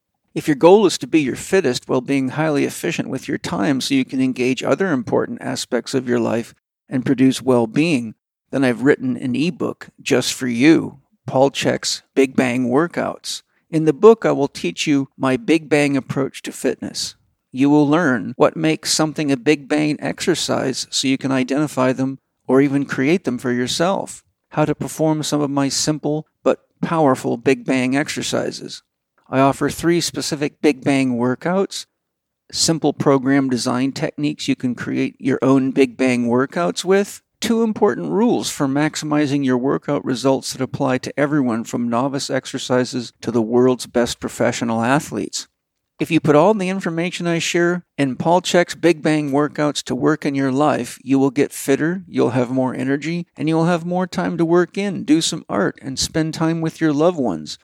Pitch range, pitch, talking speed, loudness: 130-160 Hz, 145 Hz, 185 wpm, -19 LUFS